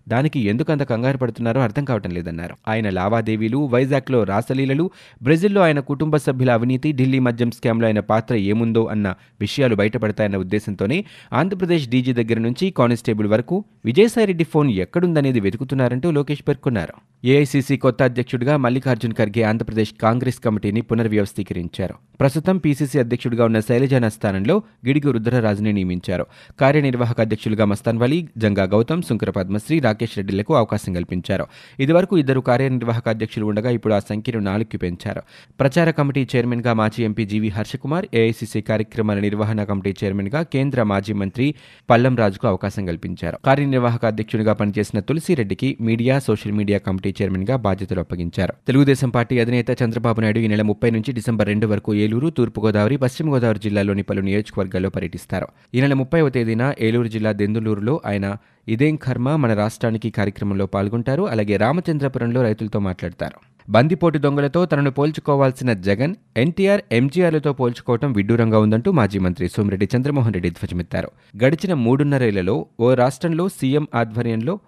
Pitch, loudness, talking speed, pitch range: 115 Hz, -20 LUFS, 130 wpm, 105-135 Hz